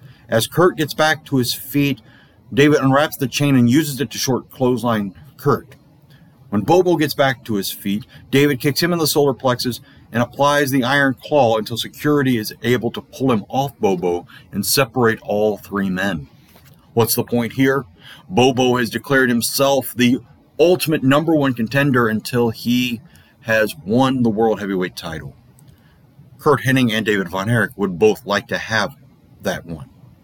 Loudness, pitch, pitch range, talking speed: -18 LUFS, 125 Hz, 115-140 Hz, 170 wpm